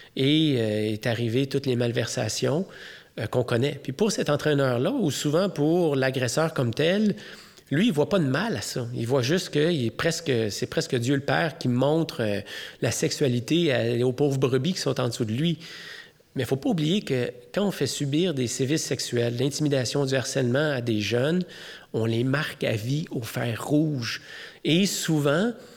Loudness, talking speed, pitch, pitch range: -25 LUFS, 195 wpm, 140 Hz, 125-160 Hz